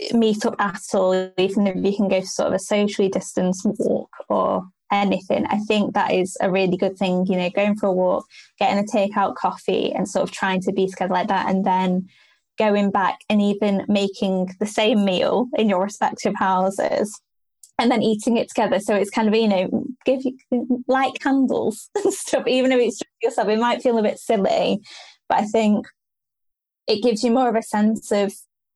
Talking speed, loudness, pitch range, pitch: 205 wpm, -21 LUFS, 195-240 Hz, 210 Hz